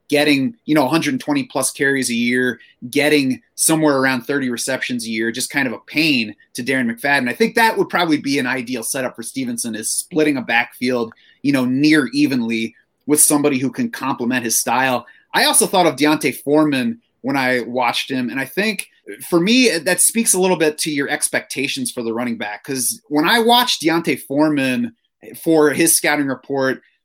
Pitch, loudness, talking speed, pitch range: 145 Hz, -17 LUFS, 190 wpm, 125-190 Hz